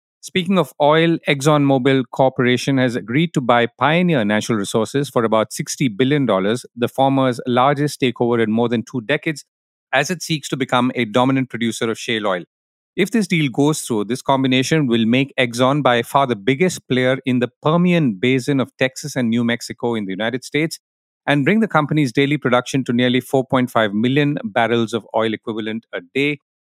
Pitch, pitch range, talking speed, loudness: 130 Hz, 120-145 Hz, 180 wpm, -18 LUFS